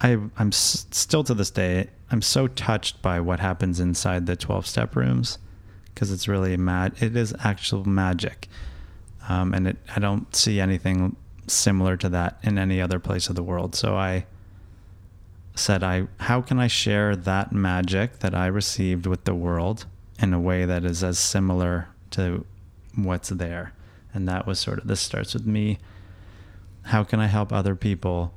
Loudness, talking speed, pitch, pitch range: -24 LUFS, 175 wpm, 95 Hz, 90-105 Hz